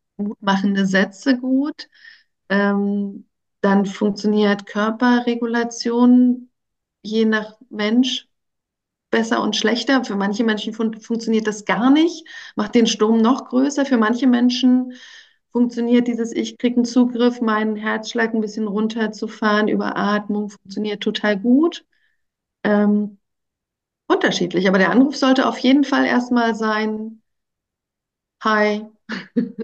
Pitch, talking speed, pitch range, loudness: 225 Hz, 115 wpm, 210-245 Hz, -19 LUFS